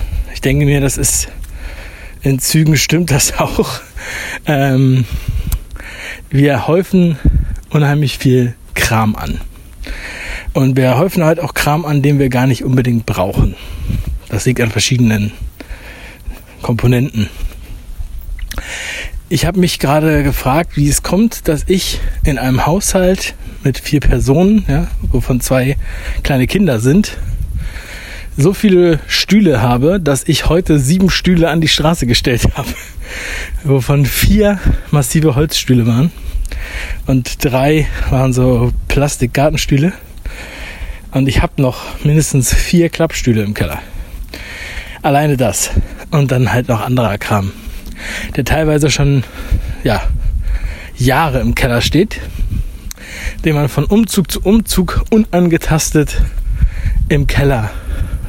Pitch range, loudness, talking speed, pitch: 100-155 Hz, -14 LUFS, 115 wpm, 130 Hz